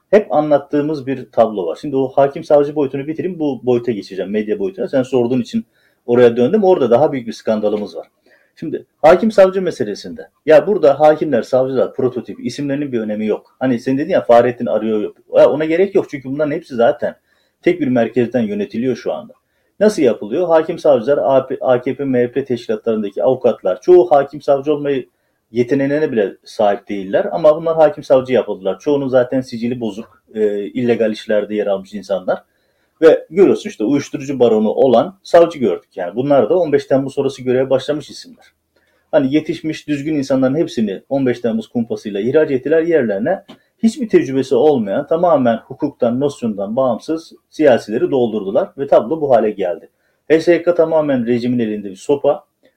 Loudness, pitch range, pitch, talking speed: -16 LUFS, 120-155 Hz, 140 Hz, 155 wpm